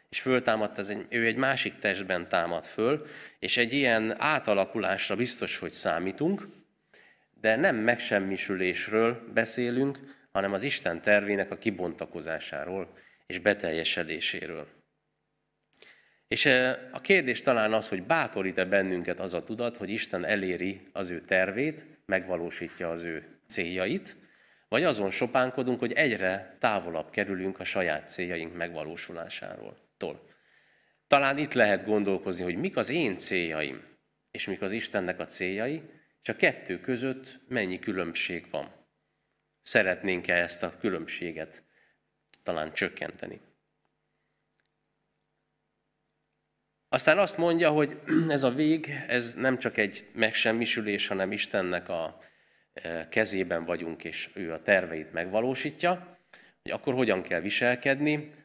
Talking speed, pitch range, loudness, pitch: 120 wpm, 95-130 Hz, -29 LUFS, 110 Hz